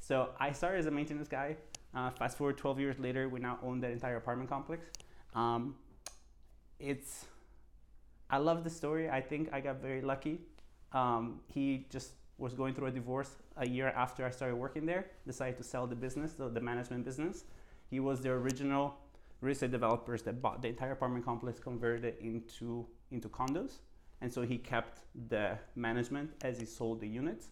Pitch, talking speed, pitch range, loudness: 130 Hz, 185 wpm, 120-140 Hz, -39 LUFS